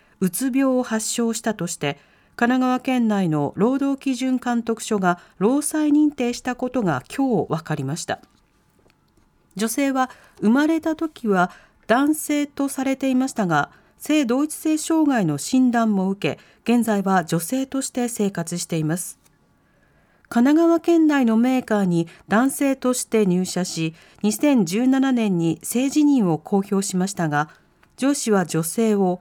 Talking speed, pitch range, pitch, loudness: 260 characters per minute, 185-270 Hz, 230 Hz, -21 LUFS